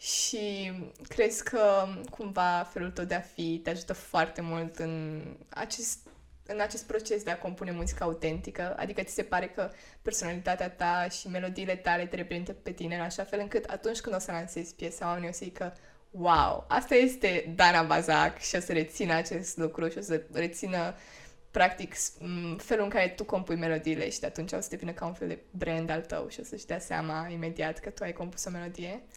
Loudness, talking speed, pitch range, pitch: -31 LUFS, 200 wpm, 165-195 Hz, 175 Hz